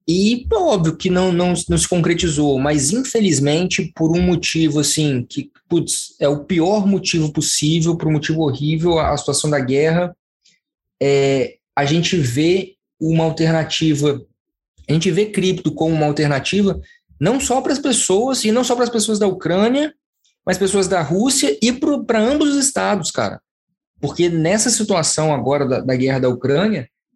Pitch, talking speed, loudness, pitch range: 170 Hz, 165 wpm, -17 LUFS, 150-205 Hz